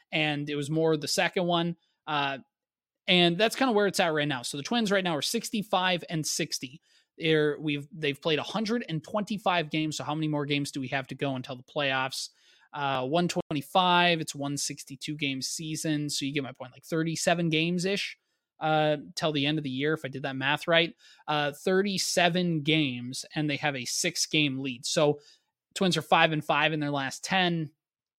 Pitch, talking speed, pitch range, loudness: 155 Hz, 205 wpm, 145-175 Hz, -28 LUFS